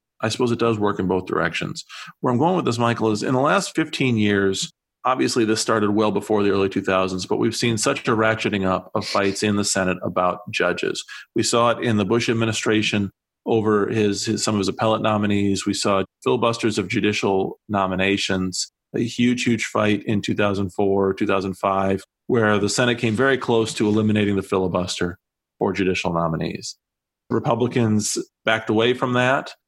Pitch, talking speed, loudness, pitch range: 105 Hz, 180 wpm, -21 LUFS, 100-115 Hz